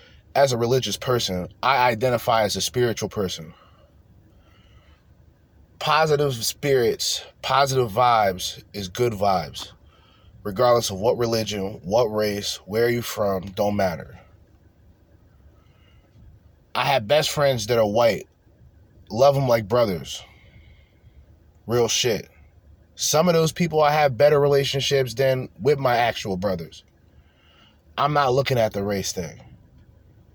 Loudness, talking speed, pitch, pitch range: -22 LUFS, 125 wpm, 105 Hz, 90-125 Hz